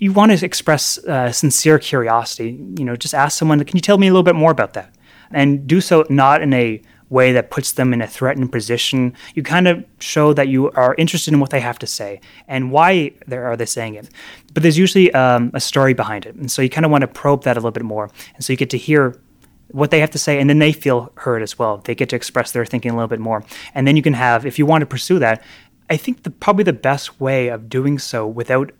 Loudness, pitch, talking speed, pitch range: -16 LUFS, 135 Hz, 265 wpm, 120-155 Hz